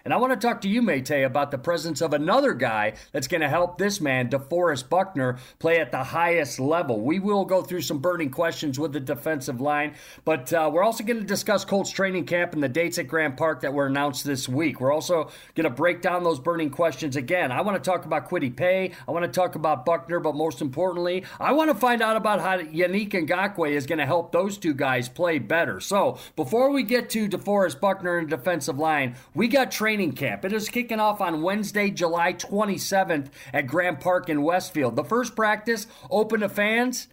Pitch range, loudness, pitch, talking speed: 155-200 Hz, -24 LUFS, 175 Hz, 220 wpm